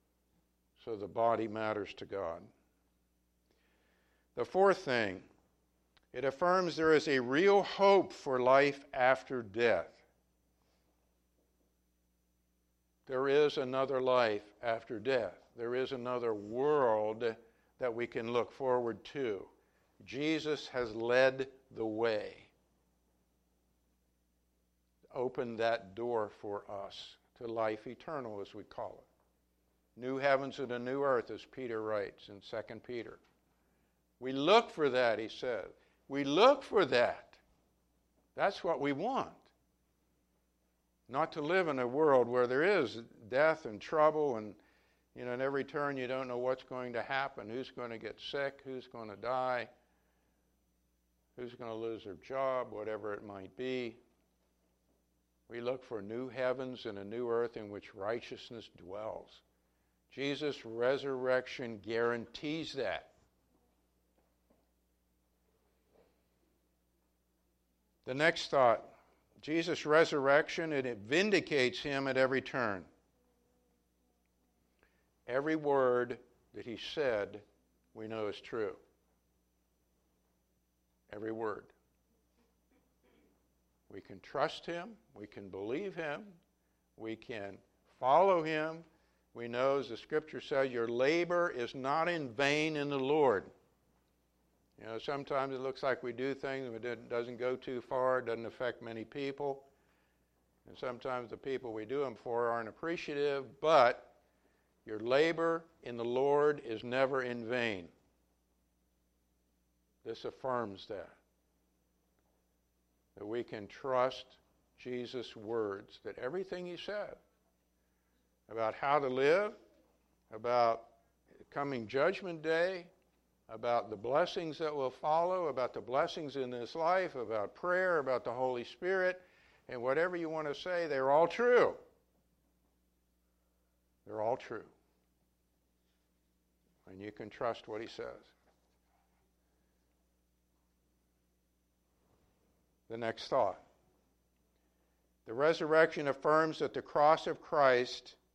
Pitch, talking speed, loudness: 115 Hz, 120 wpm, -34 LUFS